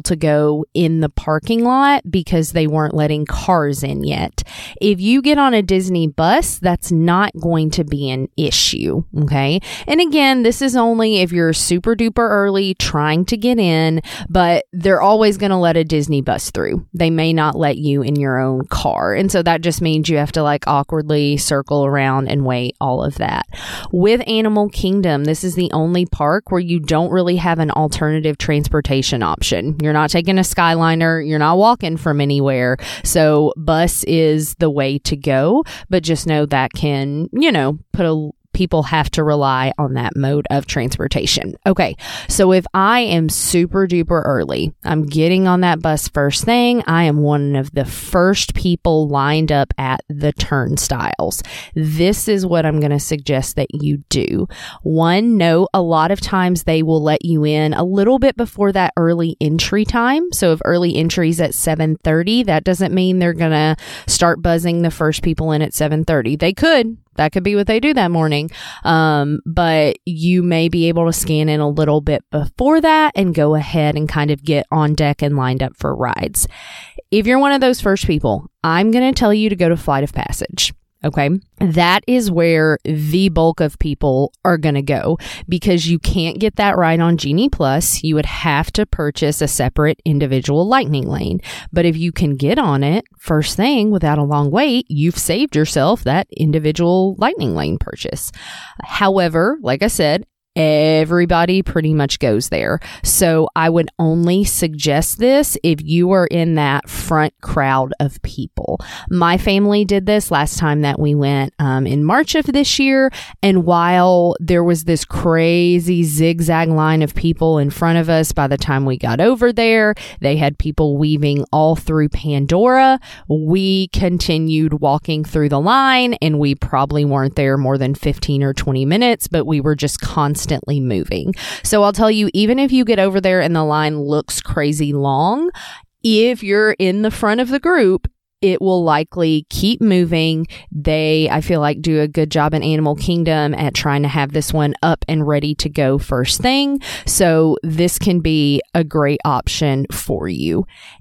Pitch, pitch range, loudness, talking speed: 160 Hz, 150-185 Hz, -15 LUFS, 185 wpm